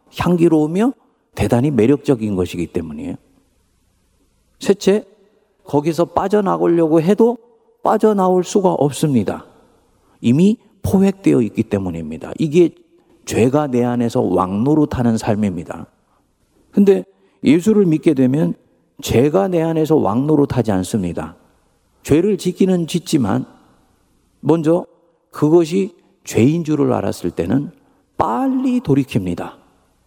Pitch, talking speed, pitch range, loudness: 155 Hz, 255 characters per minute, 115-195 Hz, -17 LUFS